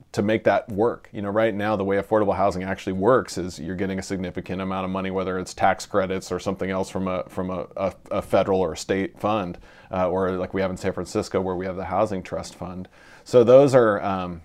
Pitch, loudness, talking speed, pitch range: 95 Hz, -23 LUFS, 240 wpm, 90-95 Hz